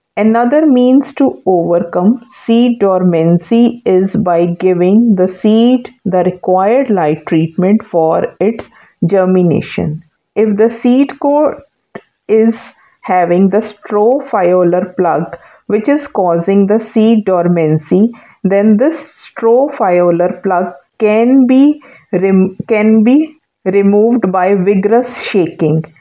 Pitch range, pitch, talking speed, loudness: 180-235 Hz, 205 Hz, 105 wpm, -11 LUFS